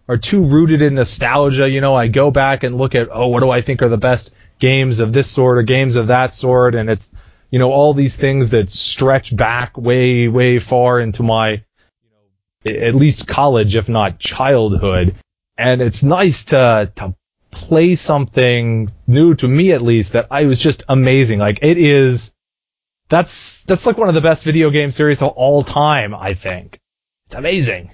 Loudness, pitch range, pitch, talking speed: -13 LUFS, 110-140 Hz, 125 Hz, 195 wpm